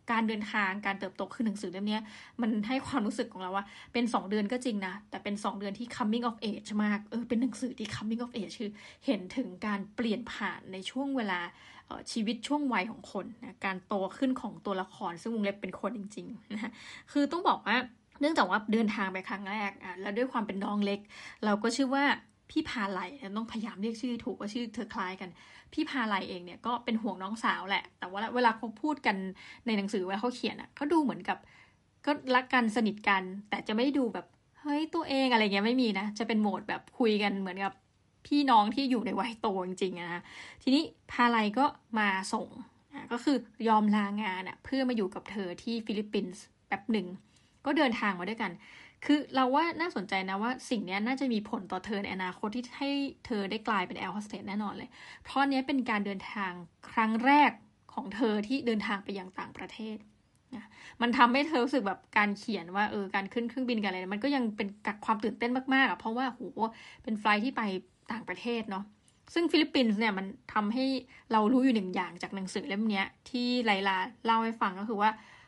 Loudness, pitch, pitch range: -32 LUFS, 225 Hz, 200-245 Hz